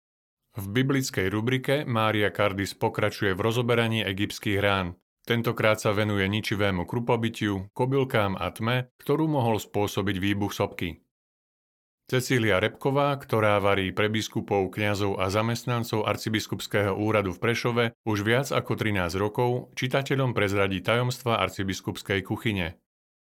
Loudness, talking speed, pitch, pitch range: -26 LUFS, 120 wpm, 110 Hz, 100-120 Hz